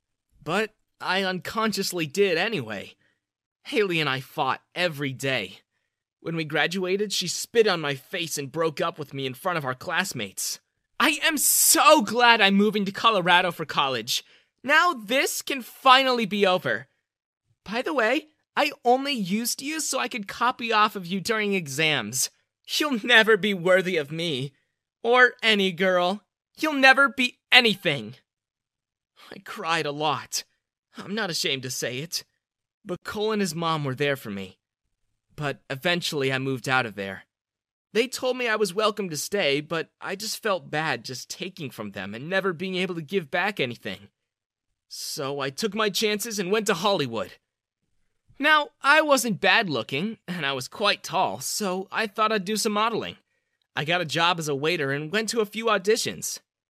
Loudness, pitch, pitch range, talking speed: -24 LUFS, 190 Hz, 145-220 Hz, 175 wpm